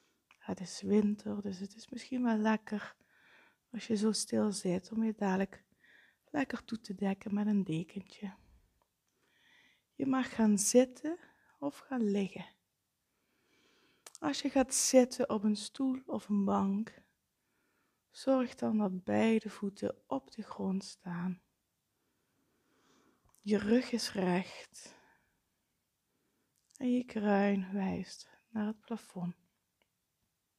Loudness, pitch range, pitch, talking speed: -34 LUFS, 195-240 Hz, 210 Hz, 120 wpm